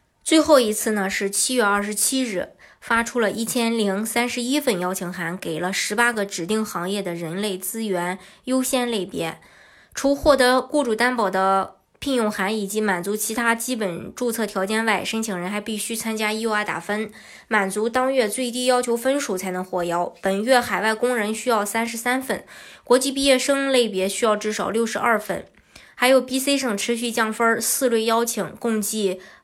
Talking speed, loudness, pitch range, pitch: 280 characters per minute, -22 LUFS, 200-245 Hz, 220 Hz